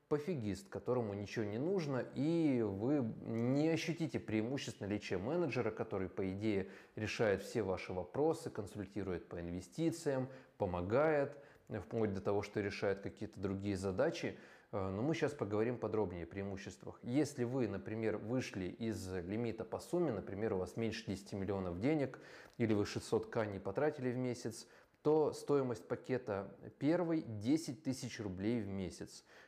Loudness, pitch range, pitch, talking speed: -39 LUFS, 100-135 Hz, 110 Hz, 145 wpm